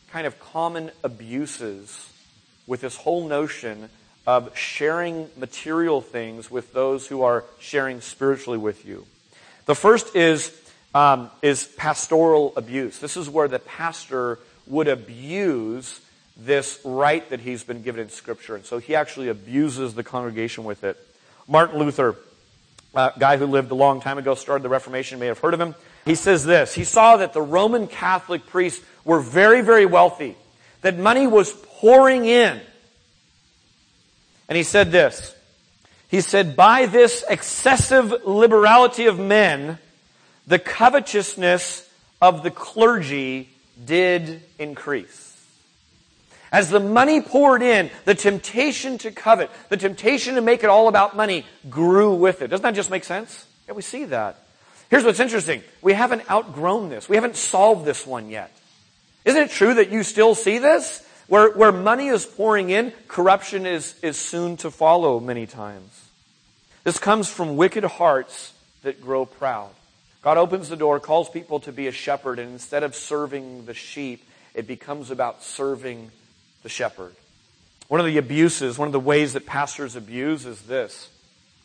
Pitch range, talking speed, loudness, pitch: 135-205 Hz, 160 wpm, -19 LUFS, 165 Hz